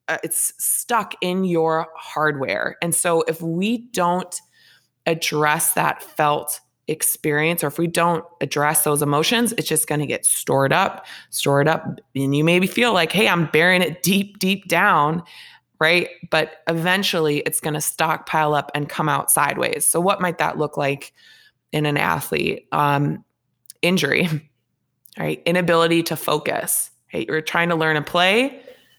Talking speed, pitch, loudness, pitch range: 160 wpm, 160 Hz, -20 LUFS, 150-175 Hz